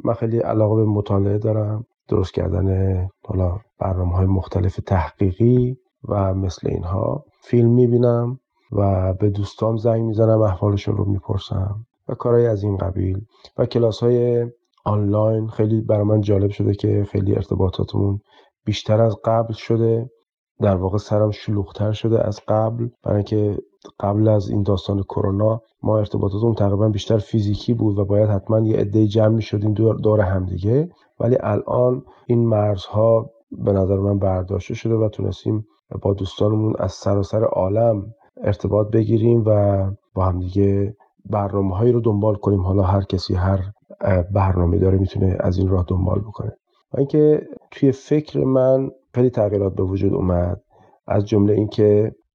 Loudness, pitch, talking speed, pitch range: -20 LUFS, 105 Hz, 150 wpm, 100-115 Hz